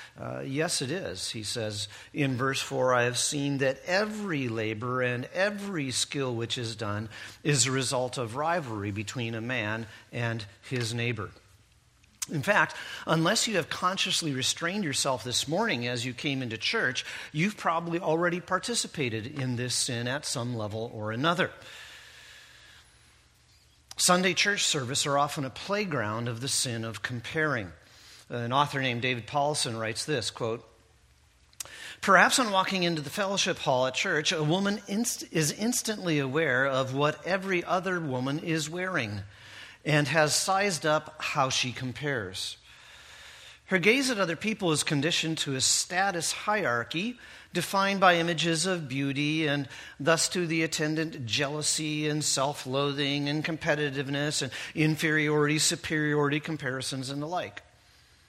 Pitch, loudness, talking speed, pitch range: 145 Hz, -28 LUFS, 145 wpm, 125-170 Hz